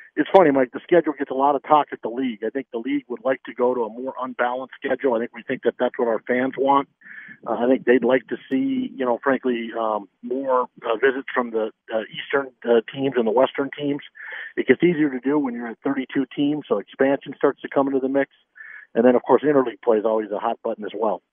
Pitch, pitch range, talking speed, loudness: 130 Hz, 125-140 Hz, 255 wpm, -22 LUFS